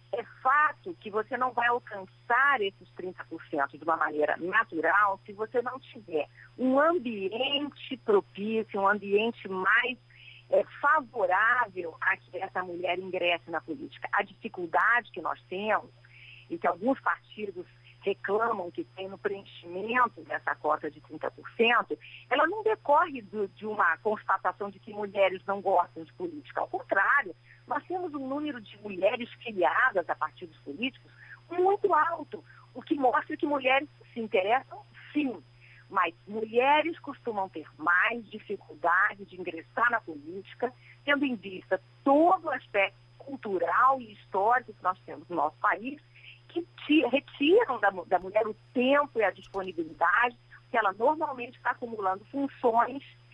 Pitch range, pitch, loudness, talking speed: 175-255 Hz, 205 Hz, -28 LUFS, 140 wpm